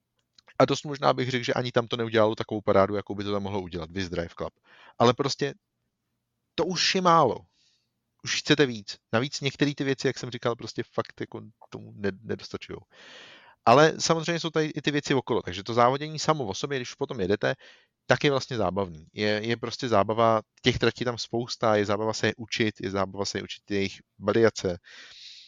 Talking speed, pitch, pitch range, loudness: 195 wpm, 115 Hz, 105-135 Hz, -26 LUFS